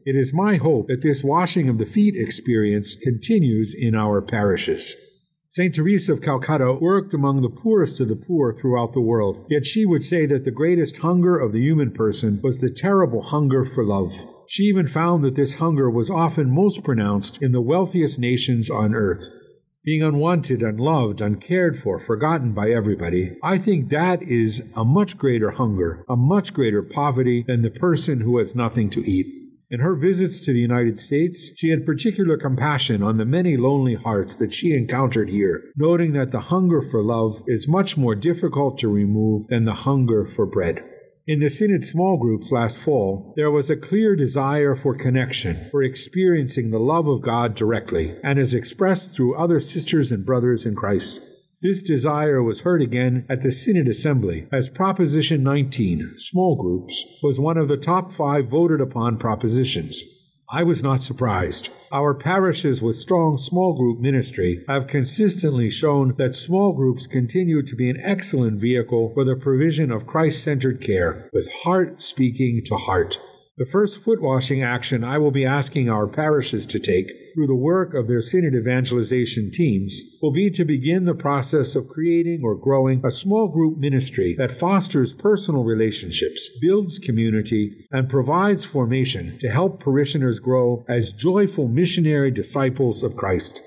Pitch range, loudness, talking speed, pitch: 120-165 Hz, -20 LUFS, 175 wpm, 135 Hz